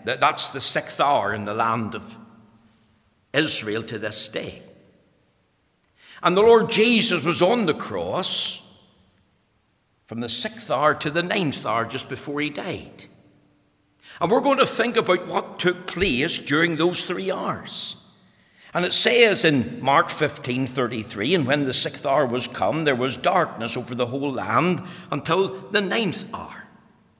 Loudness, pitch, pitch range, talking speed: -21 LUFS, 145 Hz, 115-180 Hz, 155 wpm